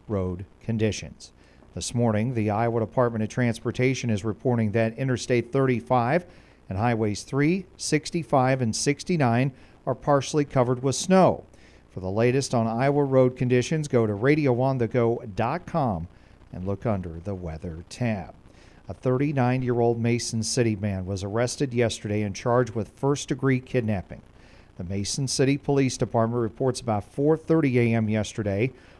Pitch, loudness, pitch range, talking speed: 120 Hz, -25 LUFS, 105-135 Hz, 140 wpm